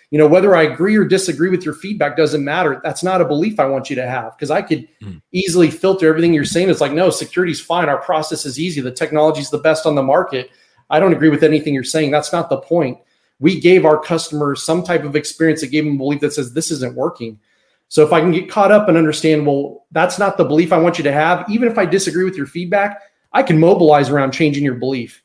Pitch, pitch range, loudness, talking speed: 160 Hz, 145-175 Hz, -15 LUFS, 255 wpm